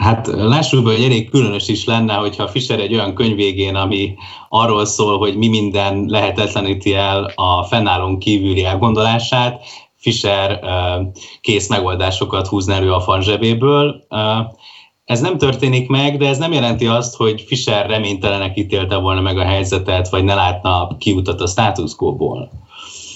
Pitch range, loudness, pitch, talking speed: 100-115 Hz, -15 LUFS, 105 Hz, 145 wpm